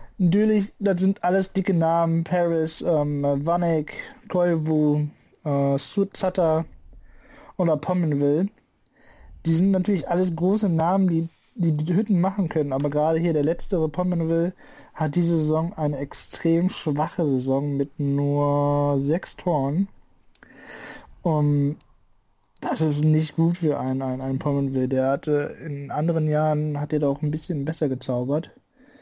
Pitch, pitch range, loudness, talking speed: 160 Hz, 145-175 Hz, -23 LUFS, 135 wpm